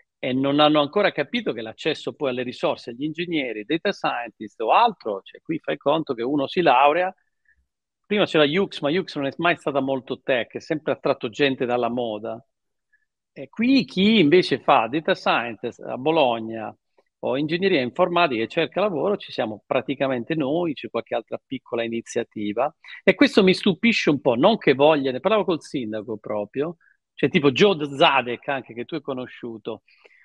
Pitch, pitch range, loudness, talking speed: 145 Hz, 120-185 Hz, -22 LUFS, 175 wpm